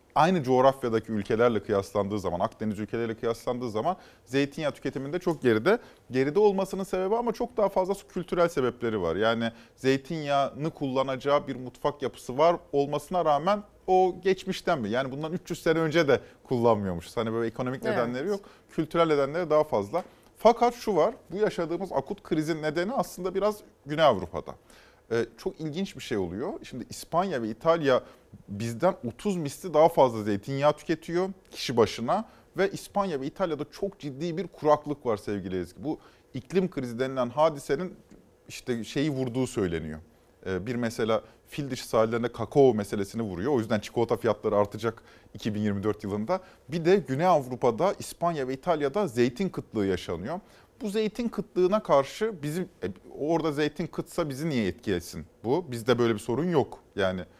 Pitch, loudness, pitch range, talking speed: 145 Hz, -28 LUFS, 115-180 Hz, 150 wpm